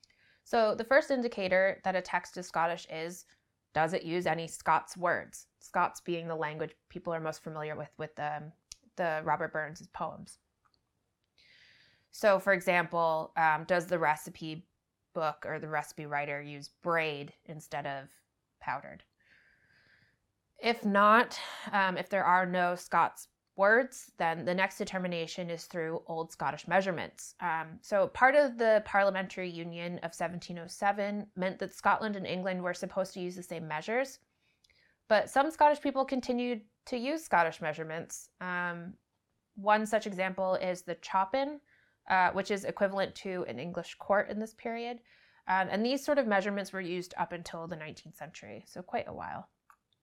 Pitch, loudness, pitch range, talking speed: 180 Hz, -32 LUFS, 165-205 Hz, 155 wpm